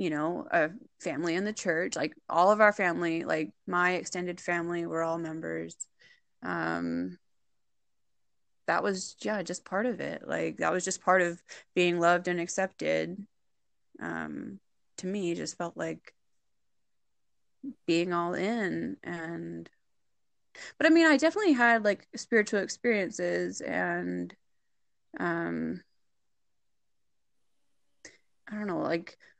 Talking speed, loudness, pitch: 130 wpm, -29 LUFS, 175 Hz